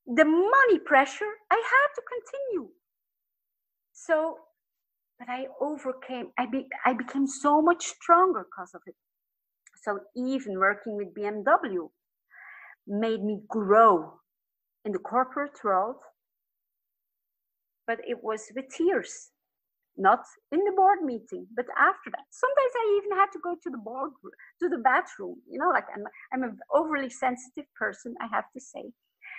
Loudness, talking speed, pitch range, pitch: -26 LUFS, 145 wpm, 245-355 Hz, 280 Hz